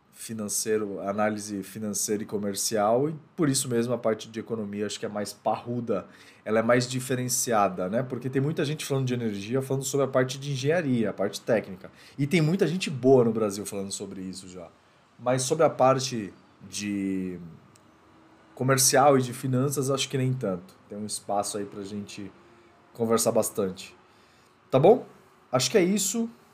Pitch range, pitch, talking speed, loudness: 100-135 Hz, 115 Hz, 175 wpm, -26 LUFS